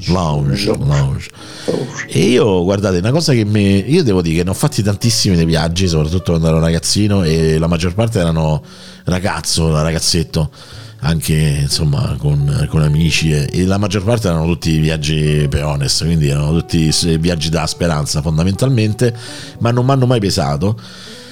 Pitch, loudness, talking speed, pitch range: 90 Hz, -15 LUFS, 160 wpm, 80-110 Hz